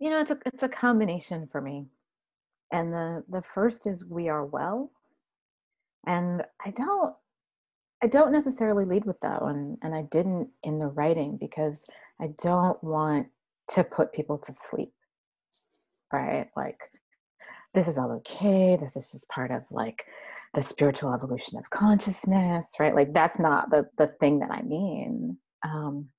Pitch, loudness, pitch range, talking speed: 170 Hz, -28 LUFS, 150-205 Hz, 160 wpm